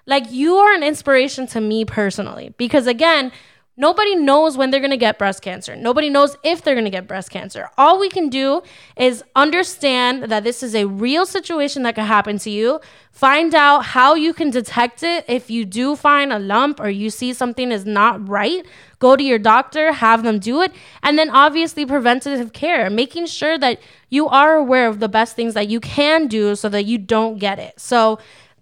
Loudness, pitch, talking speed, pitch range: -16 LUFS, 255 Hz, 210 wpm, 225-295 Hz